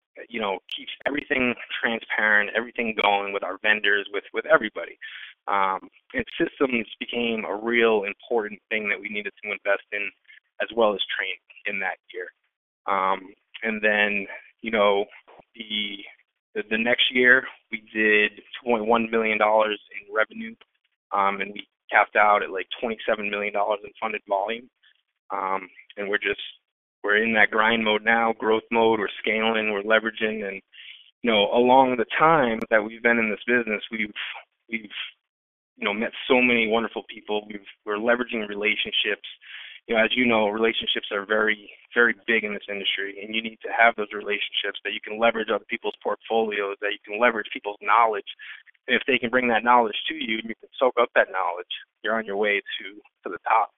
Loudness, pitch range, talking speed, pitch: -23 LUFS, 105-115 Hz, 180 wpm, 110 Hz